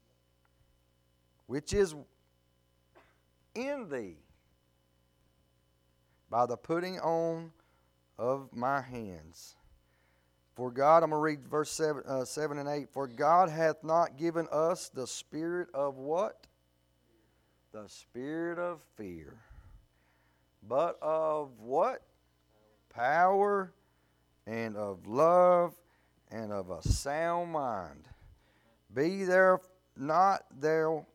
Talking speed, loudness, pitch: 100 wpm, -31 LUFS, 115 Hz